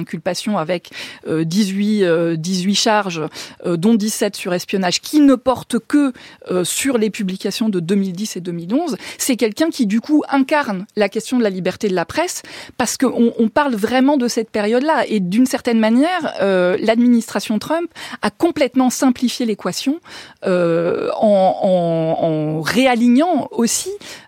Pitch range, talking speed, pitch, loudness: 190-260 Hz, 140 wpm, 220 Hz, -17 LUFS